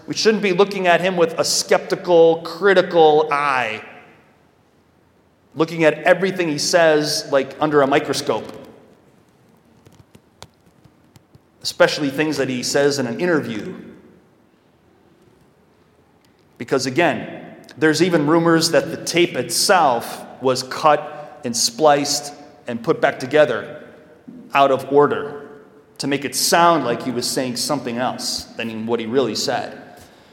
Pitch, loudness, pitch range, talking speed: 150 Hz, -18 LUFS, 135-165 Hz, 125 wpm